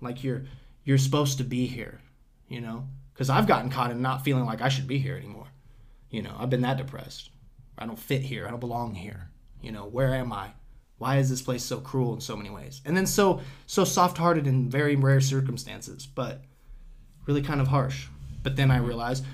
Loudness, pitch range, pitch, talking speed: -27 LUFS, 120-135 Hz, 130 Hz, 215 wpm